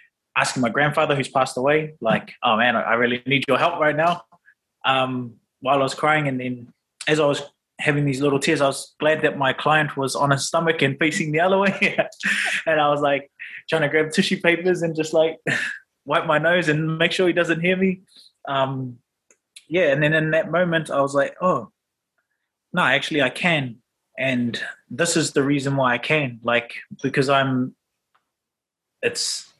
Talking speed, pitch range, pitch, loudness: 190 wpm, 135-165 Hz, 145 Hz, -21 LUFS